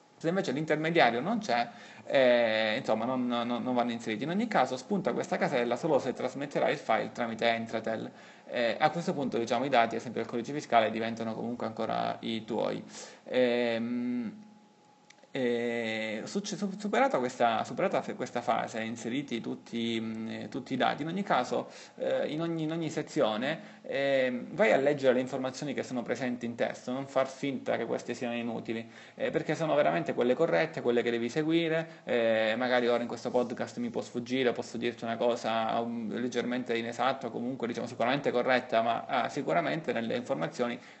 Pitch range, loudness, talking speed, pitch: 115-155 Hz, -31 LUFS, 170 wpm, 120 Hz